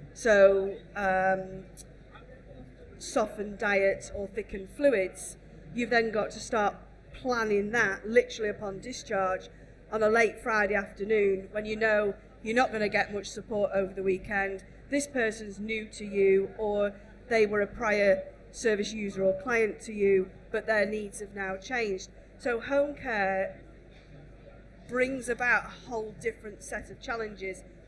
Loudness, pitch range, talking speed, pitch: -29 LUFS, 195-220 Hz, 145 wpm, 210 Hz